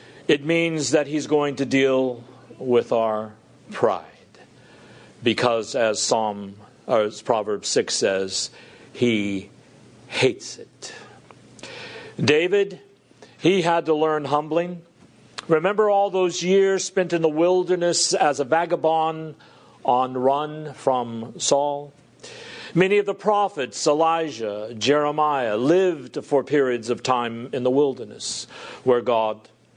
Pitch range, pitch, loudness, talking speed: 120-165 Hz, 145 Hz, -22 LUFS, 115 wpm